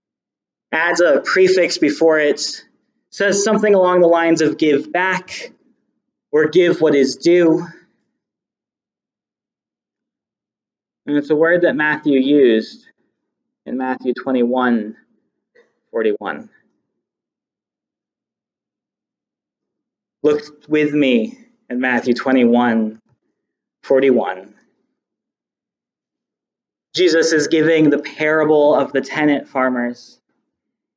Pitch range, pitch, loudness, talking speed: 130-175 Hz, 150 Hz, -16 LUFS, 85 wpm